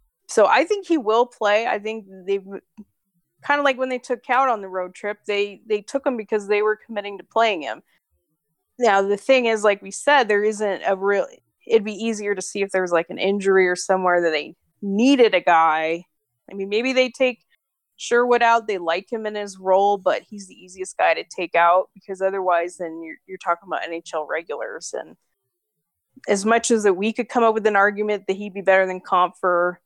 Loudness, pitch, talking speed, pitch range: -21 LUFS, 200 Hz, 215 wpm, 180-225 Hz